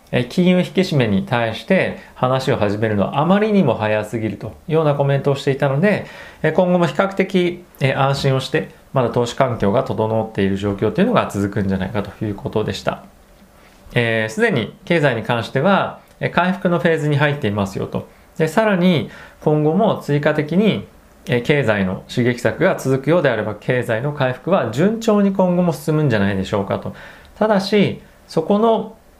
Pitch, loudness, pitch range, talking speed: 140 Hz, -18 LUFS, 110-180 Hz, 360 characters per minute